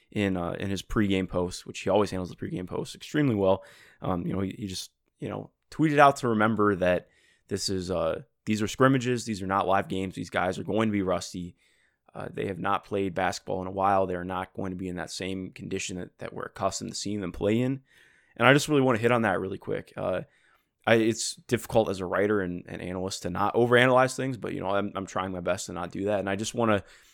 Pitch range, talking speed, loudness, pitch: 95-115 Hz, 260 wpm, -27 LUFS, 100 Hz